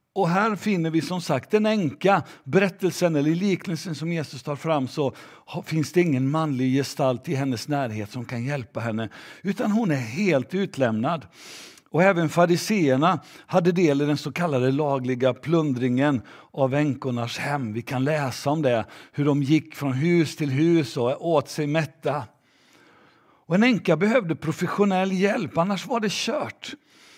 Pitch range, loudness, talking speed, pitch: 135-180 Hz, -24 LUFS, 160 wpm, 155 Hz